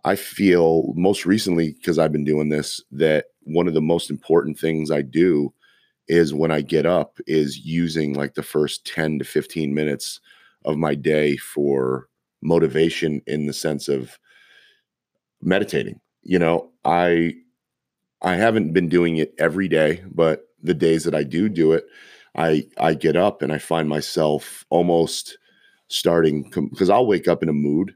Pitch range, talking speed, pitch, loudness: 75-85 Hz, 165 wpm, 80 Hz, -21 LUFS